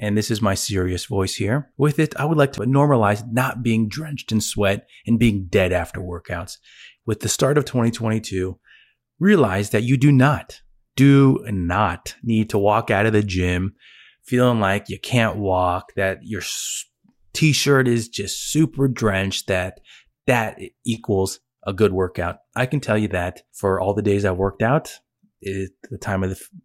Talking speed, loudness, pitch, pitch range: 180 wpm, -20 LUFS, 110 Hz, 95-130 Hz